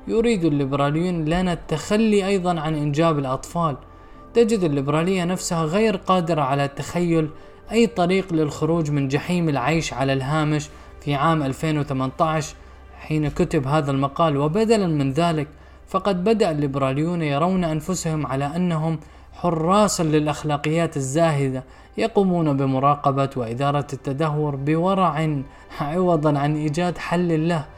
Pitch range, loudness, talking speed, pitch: 145-175 Hz, -21 LUFS, 115 wpm, 155 Hz